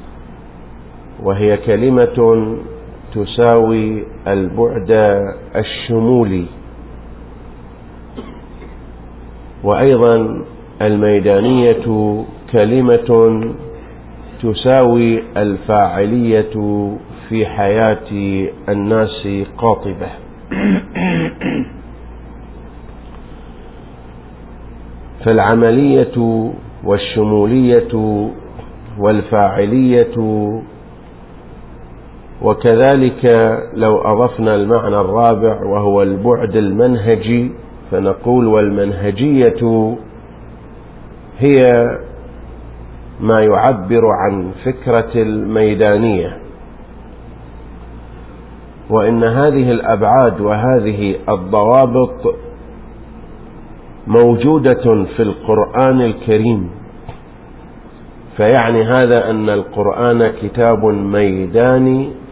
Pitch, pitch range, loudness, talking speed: 110 Hz, 100-115 Hz, -13 LUFS, 45 wpm